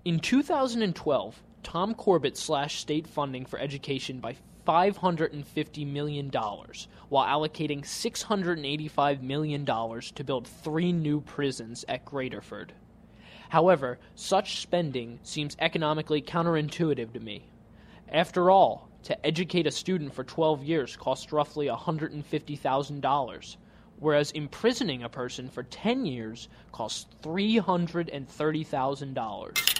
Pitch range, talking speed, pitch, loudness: 135-170 Hz, 105 wpm, 150 Hz, -29 LUFS